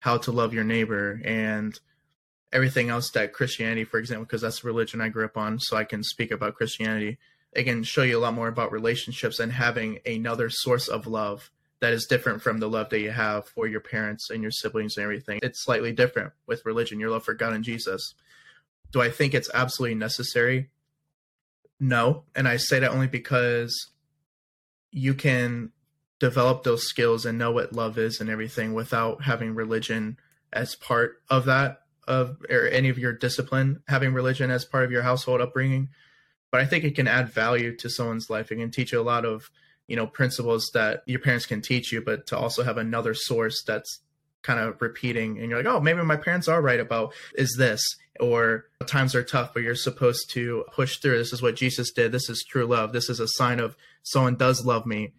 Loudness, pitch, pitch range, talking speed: -25 LUFS, 120 Hz, 115-130 Hz, 210 wpm